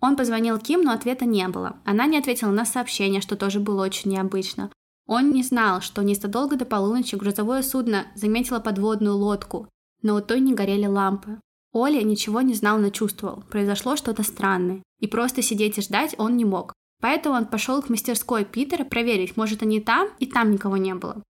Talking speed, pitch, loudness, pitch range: 190 wpm, 220 Hz, -23 LUFS, 200-245 Hz